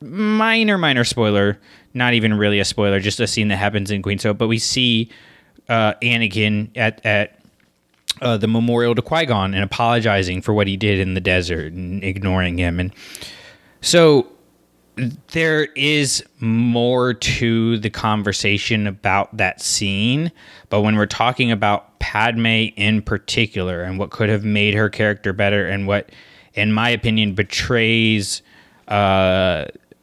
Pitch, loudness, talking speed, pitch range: 105 Hz, -18 LUFS, 150 wpm, 100-120 Hz